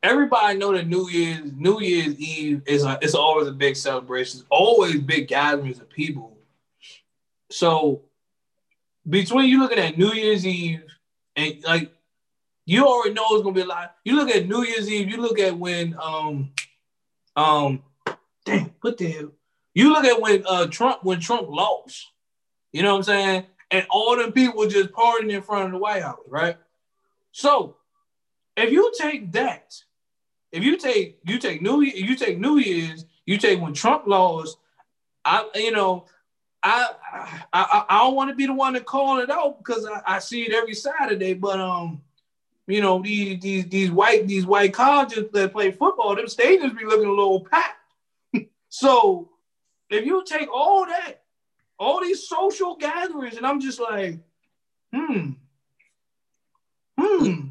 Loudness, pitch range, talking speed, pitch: -21 LUFS, 165-260 Hz, 170 wpm, 200 Hz